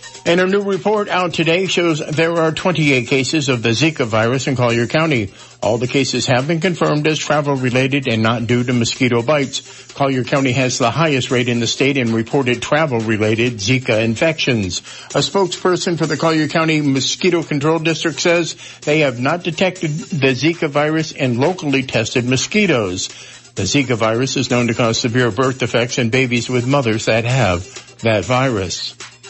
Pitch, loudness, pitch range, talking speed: 135 Hz, -16 LUFS, 125-160 Hz, 180 wpm